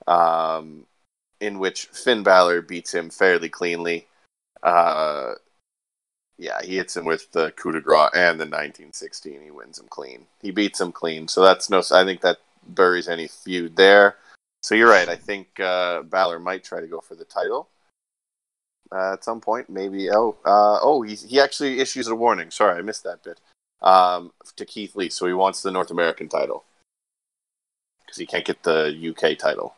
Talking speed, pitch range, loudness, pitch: 185 wpm, 85-115 Hz, -20 LUFS, 95 Hz